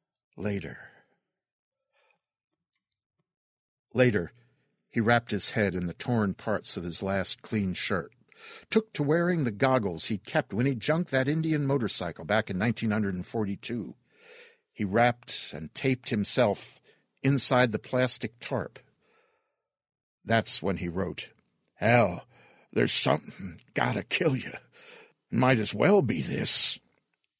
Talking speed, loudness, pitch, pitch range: 125 wpm, -28 LUFS, 115 Hz, 100-130 Hz